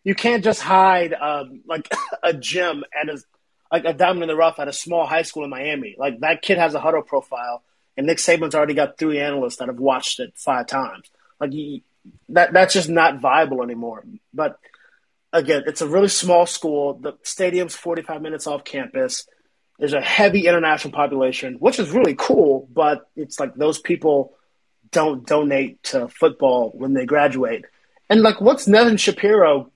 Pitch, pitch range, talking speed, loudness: 160 Hz, 145-185 Hz, 180 wpm, -19 LUFS